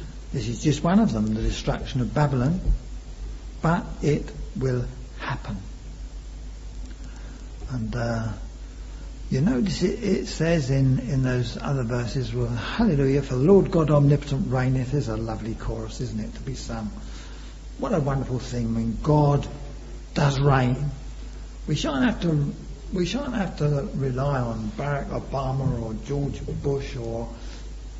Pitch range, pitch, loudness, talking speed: 115-145 Hz, 130 Hz, -25 LUFS, 145 wpm